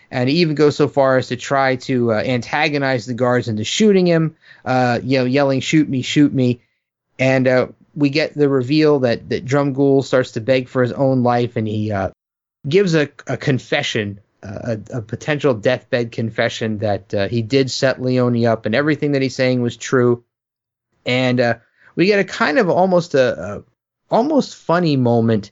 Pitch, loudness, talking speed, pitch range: 130 Hz, -17 LUFS, 195 wpm, 120-145 Hz